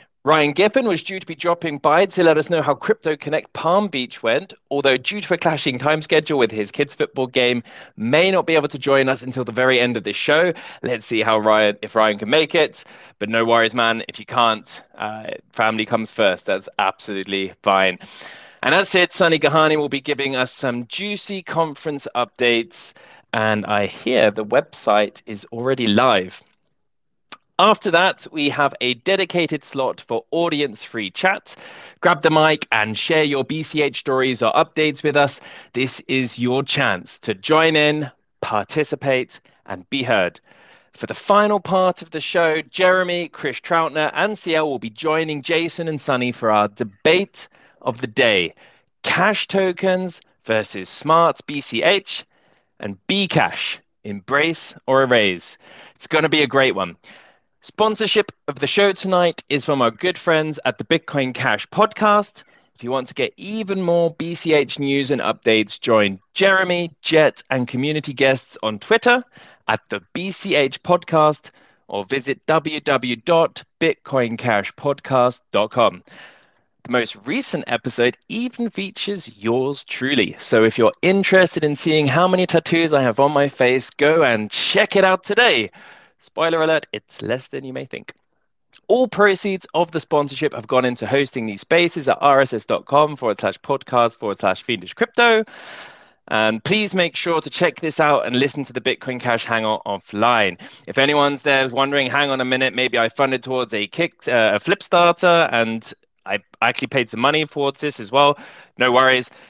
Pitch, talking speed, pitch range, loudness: 145 Hz, 165 wpm, 125-170 Hz, -19 LUFS